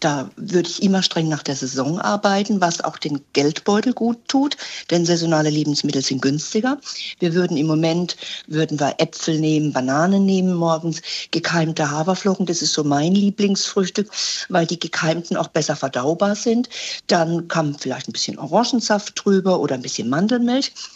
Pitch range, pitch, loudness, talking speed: 155-200 Hz, 170 Hz, -20 LUFS, 160 wpm